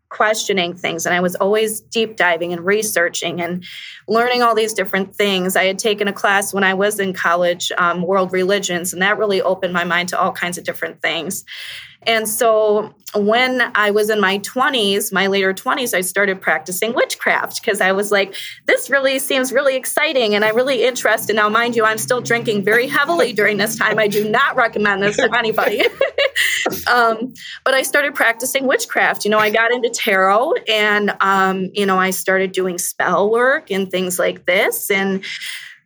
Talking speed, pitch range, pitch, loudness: 190 wpm, 190-235 Hz, 210 Hz, -16 LUFS